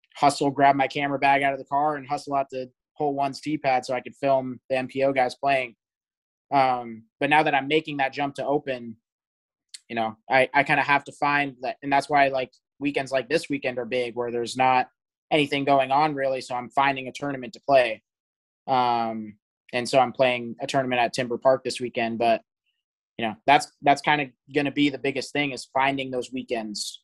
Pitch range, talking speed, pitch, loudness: 125-140 Hz, 215 wpm, 135 Hz, -24 LUFS